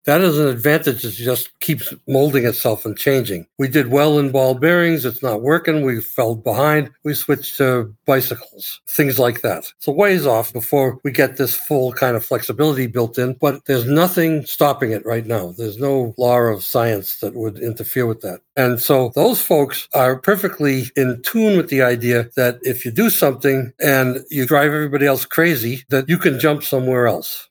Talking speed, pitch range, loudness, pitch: 195 wpm, 120-150 Hz, -17 LUFS, 135 Hz